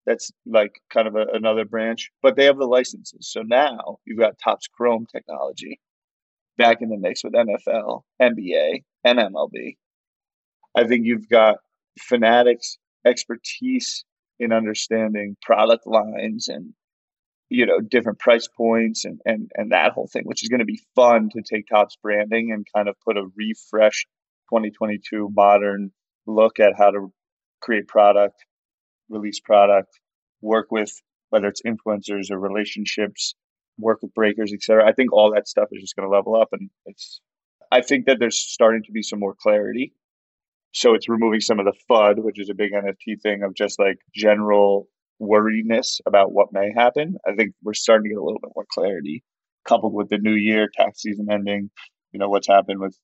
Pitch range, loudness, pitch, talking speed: 105-115 Hz, -20 LUFS, 110 Hz, 175 wpm